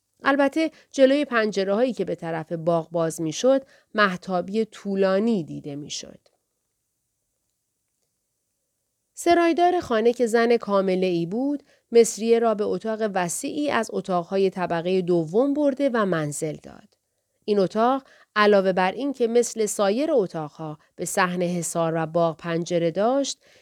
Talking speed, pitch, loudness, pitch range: 130 wpm, 205 Hz, -23 LUFS, 175-245 Hz